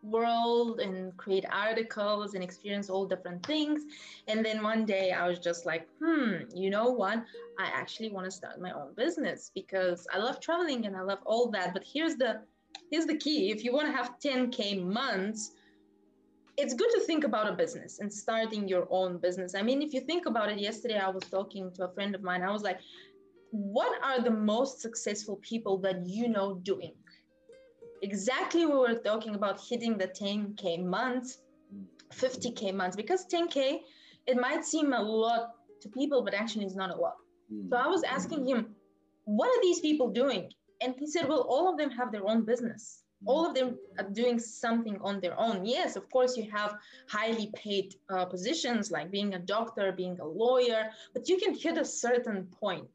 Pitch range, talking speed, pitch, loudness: 195-265 Hz, 195 wpm, 225 Hz, -32 LUFS